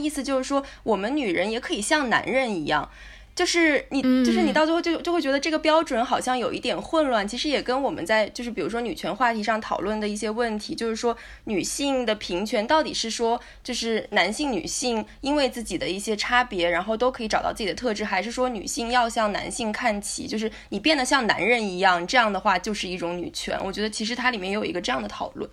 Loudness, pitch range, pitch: -24 LUFS, 215-275 Hz, 240 Hz